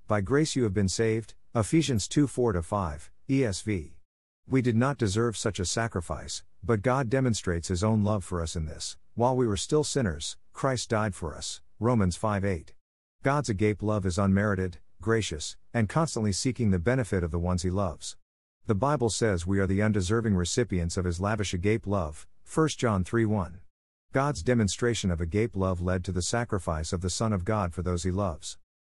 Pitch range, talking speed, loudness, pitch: 90-115 Hz, 190 wpm, -28 LUFS, 100 Hz